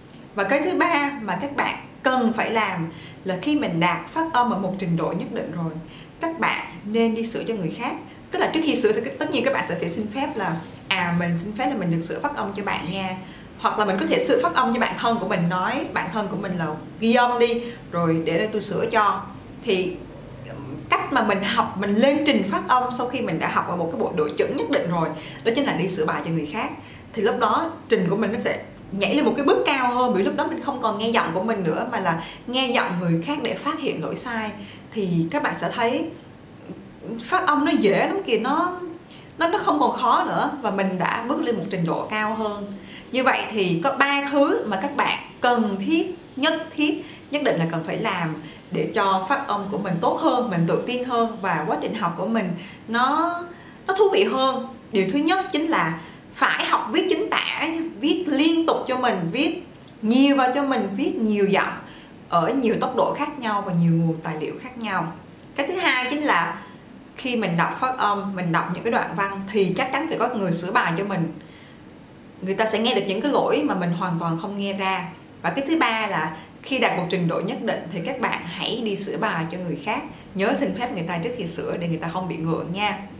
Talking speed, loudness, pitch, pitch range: 245 wpm, -23 LUFS, 215 Hz, 180-260 Hz